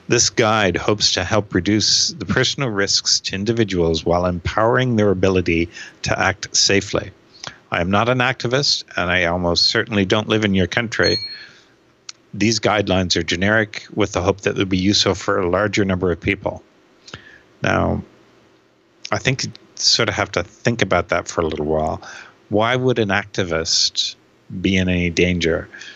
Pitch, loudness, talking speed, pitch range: 100 Hz, -18 LUFS, 165 wpm, 90-110 Hz